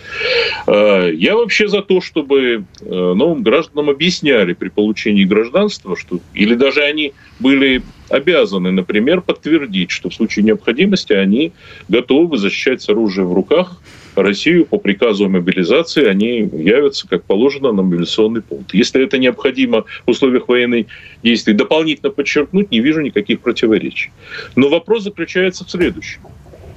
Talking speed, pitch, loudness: 130 wpm, 130 Hz, -14 LUFS